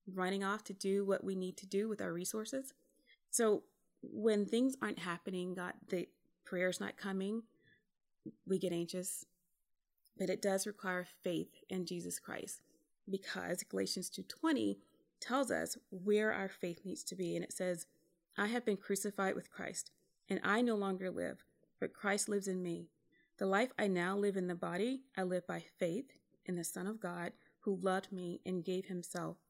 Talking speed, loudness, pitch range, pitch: 175 wpm, -39 LUFS, 180-210 Hz, 190 Hz